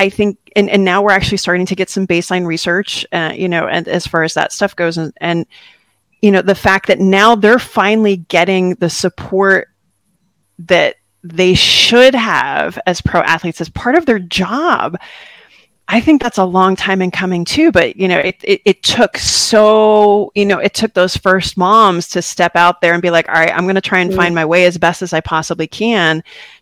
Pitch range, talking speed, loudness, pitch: 175-205 Hz, 215 wpm, -12 LUFS, 185 Hz